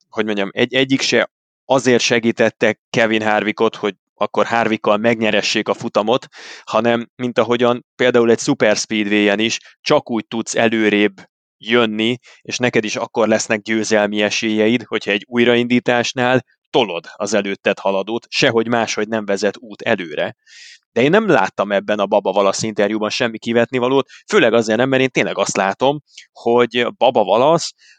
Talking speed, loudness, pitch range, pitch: 150 wpm, -17 LUFS, 105-120 Hz, 115 Hz